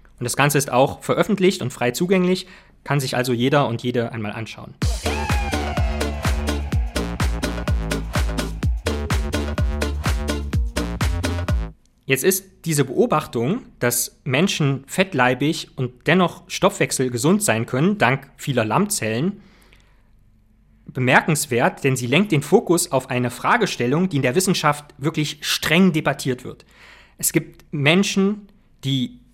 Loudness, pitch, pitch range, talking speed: -21 LUFS, 130 Hz, 110-170 Hz, 110 wpm